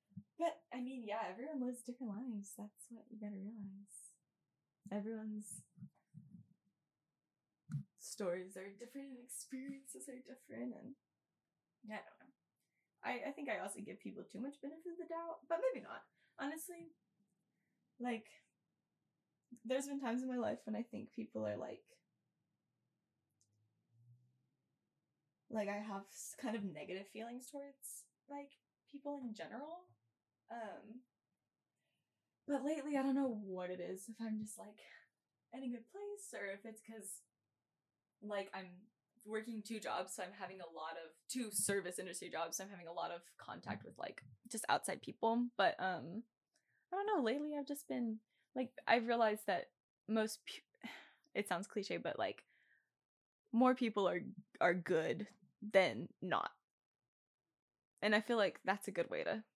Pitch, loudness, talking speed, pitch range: 220 Hz, -43 LUFS, 155 wpm, 195-255 Hz